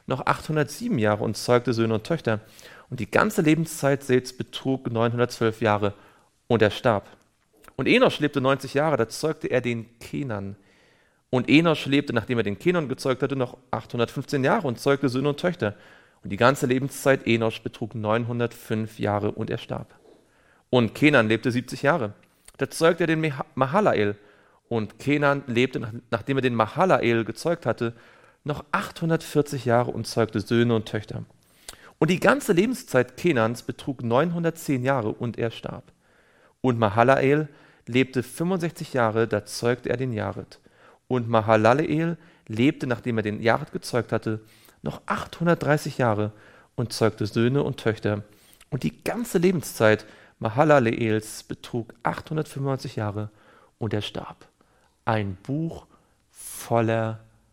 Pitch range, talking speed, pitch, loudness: 110-145 Hz, 140 wpm, 120 Hz, -24 LUFS